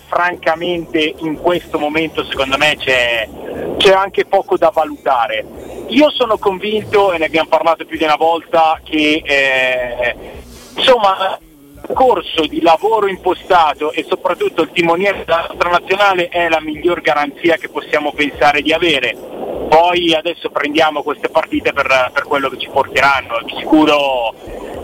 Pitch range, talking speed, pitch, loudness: 150-185 Hz, 140 wpm, 160 Hz, -14 LUFS